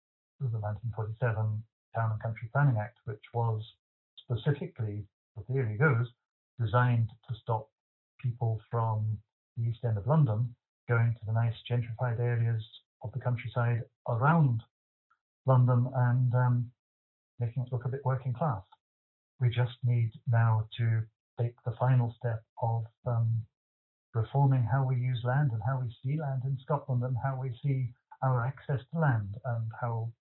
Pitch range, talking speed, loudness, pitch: 110-130 Hz, 150 wpm, -31 LUFS, 120 Hz